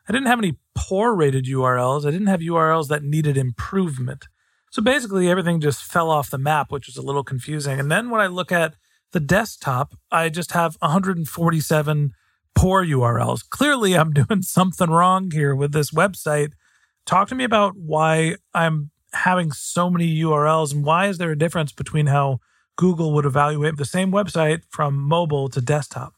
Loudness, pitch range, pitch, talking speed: -20 LUFS, 145-180 Hz, 160 Hz, 180 wpm